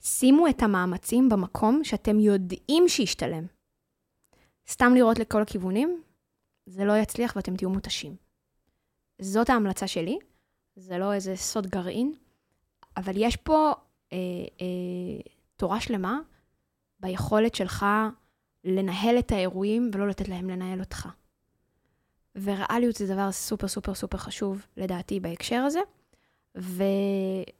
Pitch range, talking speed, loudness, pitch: 190-235 Hz, 115 wpm, -26 LUFS, 200 Hz